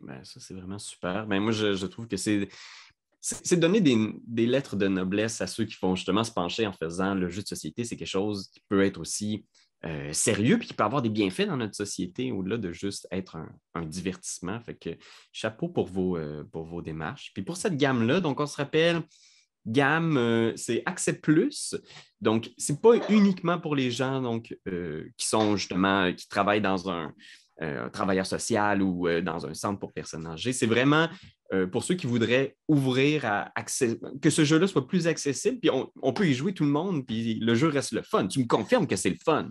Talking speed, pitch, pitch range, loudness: 225 wpm, 110 Hz, 95-135 Hz, -27 LUFS